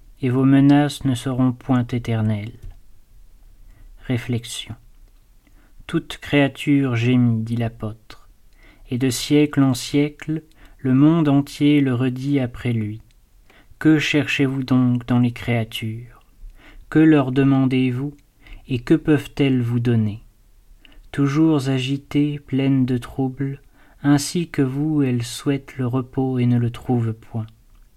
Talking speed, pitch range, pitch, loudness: 125 wpm, 115-140 Hz, 130 Hz, -20 LUFS